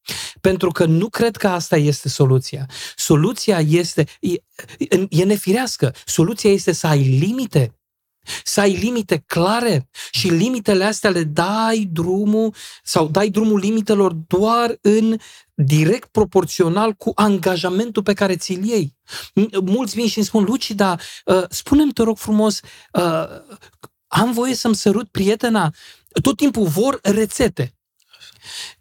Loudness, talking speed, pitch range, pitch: -18 LUFS, 130 wpm, 170-220 Hz, 200 Hz